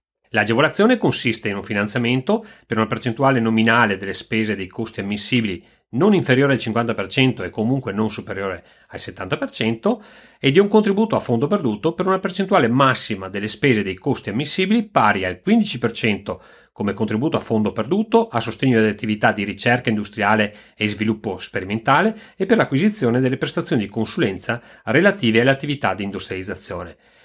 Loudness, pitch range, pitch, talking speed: -20 LUFS, 105-160 Hz, 115 Hz, 155 wpm